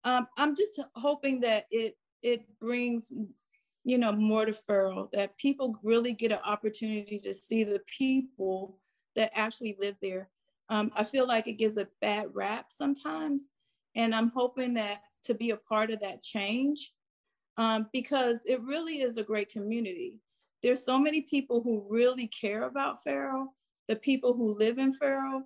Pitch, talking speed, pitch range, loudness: 230 Hz, 165 wpm, 215-265 Hz, -31 LUFS